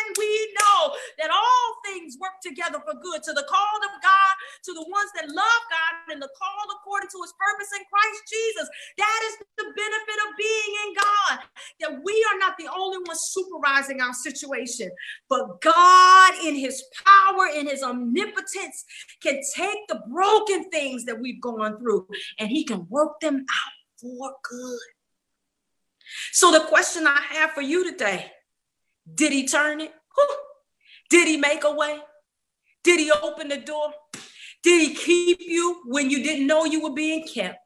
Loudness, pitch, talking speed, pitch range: -21 LUFS, 325 Hz, 170 wpm, 290-390 Hz